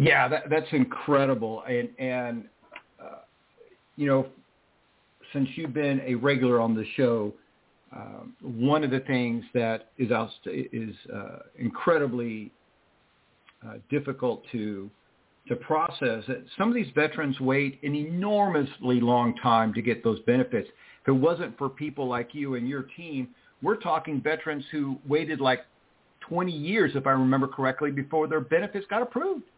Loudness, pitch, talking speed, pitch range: -27 LUFS, 135 Hz, 145 wpm, 120-150 Hz